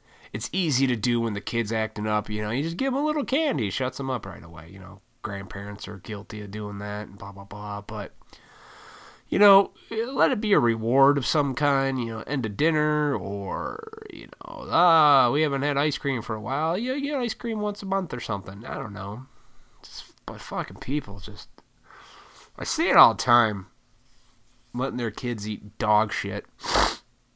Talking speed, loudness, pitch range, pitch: 205 wpm, -25 LUFS, 105-145 Hz, 120 Hz